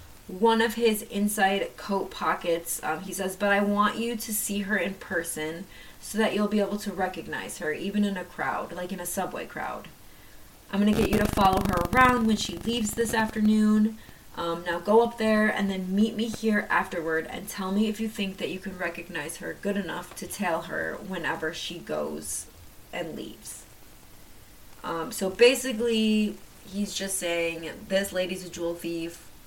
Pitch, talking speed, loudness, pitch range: 195 Hz, 185 wpm, -27 LUFS, 175-215 Hz